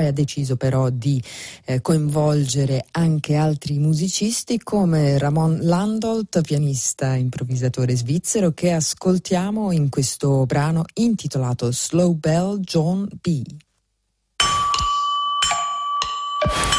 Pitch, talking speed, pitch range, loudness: 160 Hz, 90 wpm, 140-200 Hz, -20 LUFS